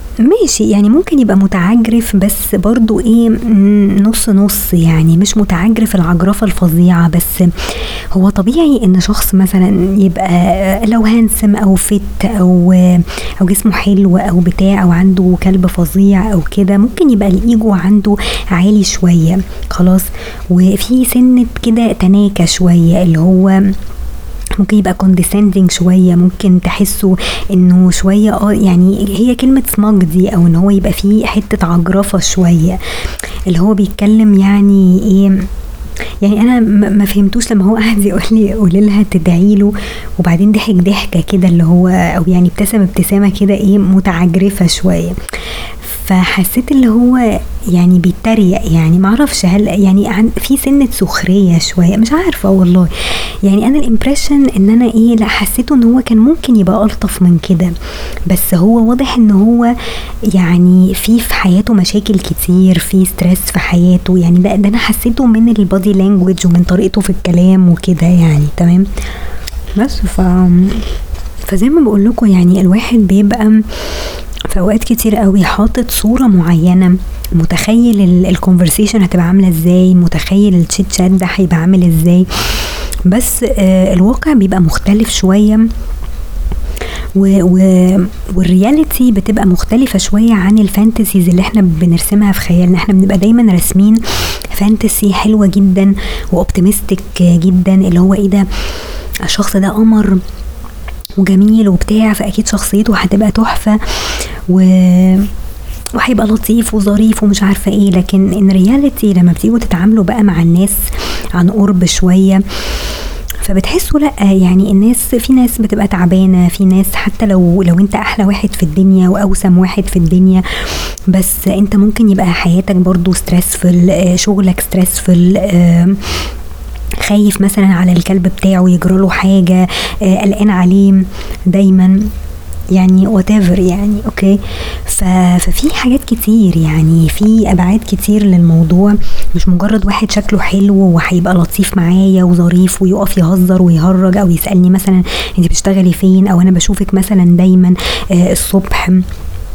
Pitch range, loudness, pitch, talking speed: 180-210 Hz, -9 LUFS, 195 Hz, 130 wpm